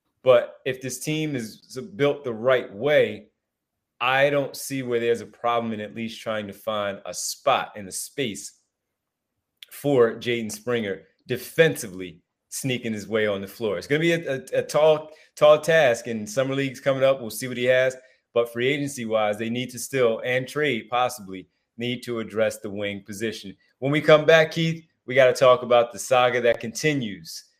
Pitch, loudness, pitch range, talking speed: 125 Hz, -23 LUFS, 110-135 Hz, 190 wpm